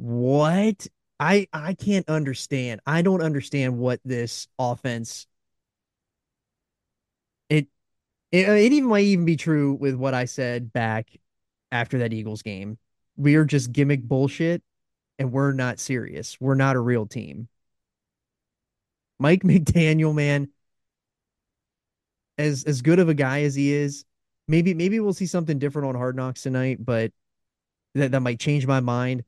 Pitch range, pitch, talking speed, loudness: 120-155 Hz, 135 Hz, 145 wpm, -23 LUFS